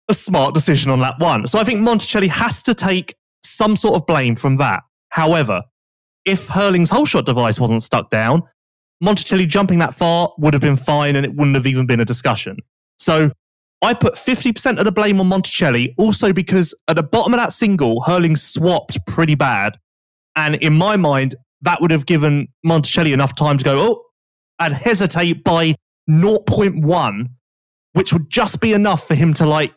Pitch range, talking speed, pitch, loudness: 140-195 Hz, 185 wpm, 165 Hz, -16 LUFS